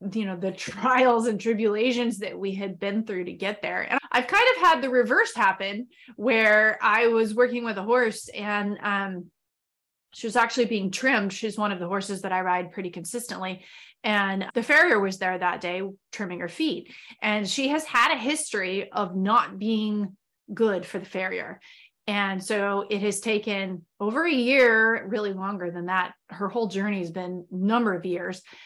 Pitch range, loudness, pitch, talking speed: 190-230 Hz, -24 LUFS, 205 Hz, 185 wpm